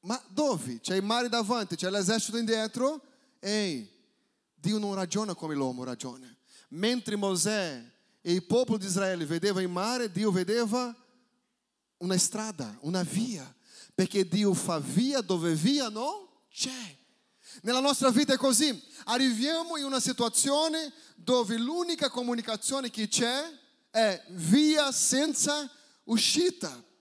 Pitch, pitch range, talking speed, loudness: 230 Hz, 195-265 Hz, 130 wpm, -28 LUFS